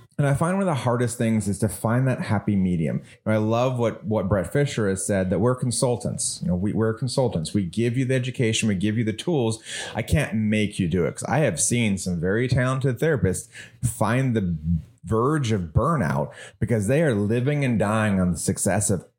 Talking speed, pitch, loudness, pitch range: 220 wpm, 115 Hz, -23 LUFS, 105-130 Hz